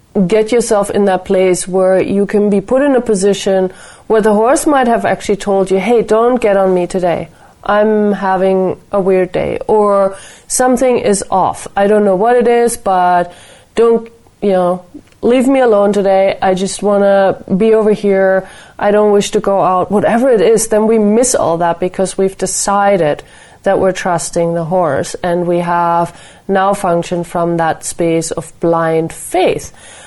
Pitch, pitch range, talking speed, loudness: 195 Hz, 185-215 Hz, 180 wpm, -12 LUFS